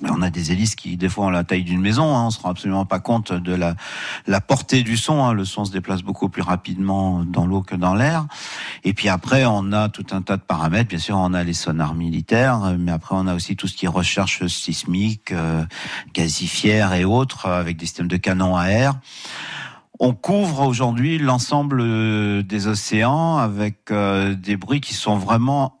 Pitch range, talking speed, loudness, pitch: 90-115 Hz, 210 wpm, -20 LUFS, 100 Hz